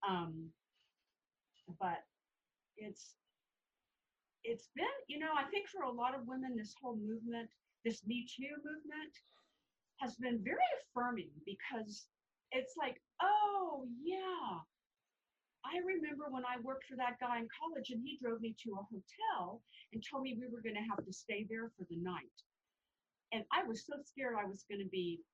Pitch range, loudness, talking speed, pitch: 220-290 Hz, -42 LUFS, 170 wpm, 245 Hz